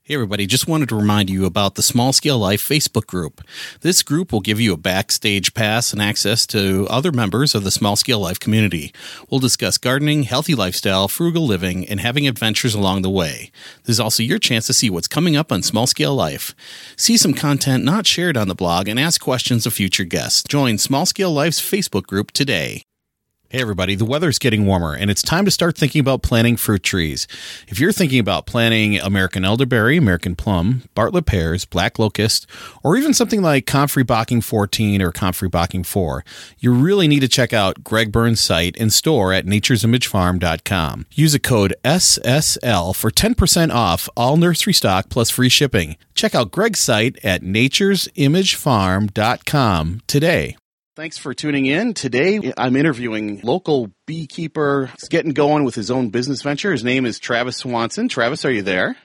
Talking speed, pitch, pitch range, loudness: 185 wpm, 120 Hz, 100-145 Hz, -17 LUFS